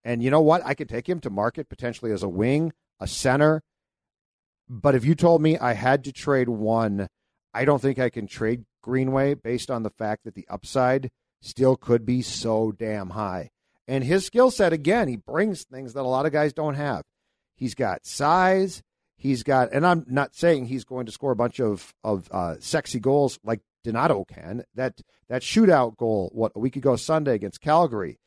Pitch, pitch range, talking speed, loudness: 130 Hz, 115-145 Hz, 200 wpm, -24 LUFS